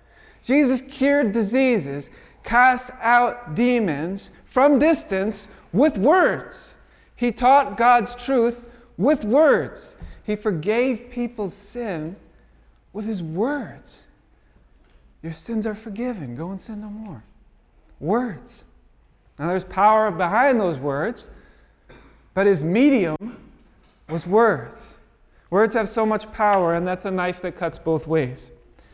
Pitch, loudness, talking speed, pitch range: 215 Hz, -21 LUFS, 120 wpm, 170-240 Hz